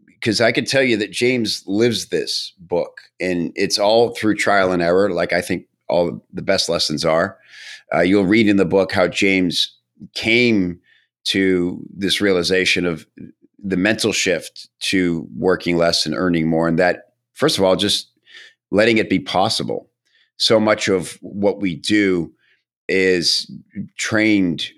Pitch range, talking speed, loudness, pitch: 90-105 Hz, 155 wpm, -18 LUFS, 95 Hz